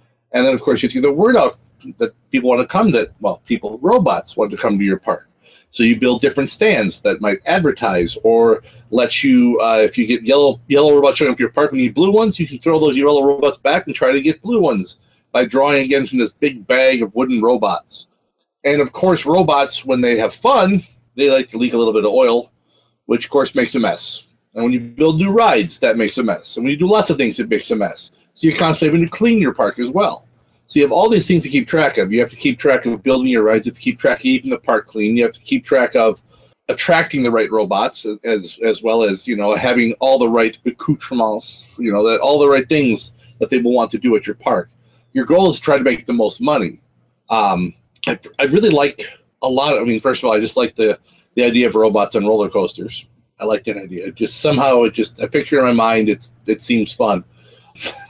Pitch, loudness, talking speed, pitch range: 135 Hz, -15 LUFS, 255 wpm, 115-160 Hz